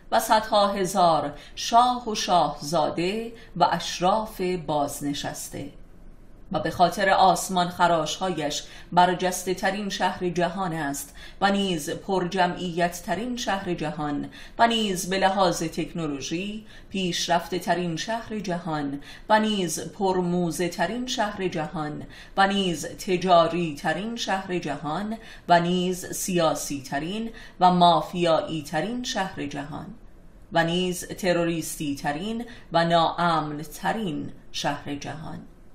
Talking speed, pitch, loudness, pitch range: 110 wpm, 175 Hz, -25 LUFS, 160-195 Hz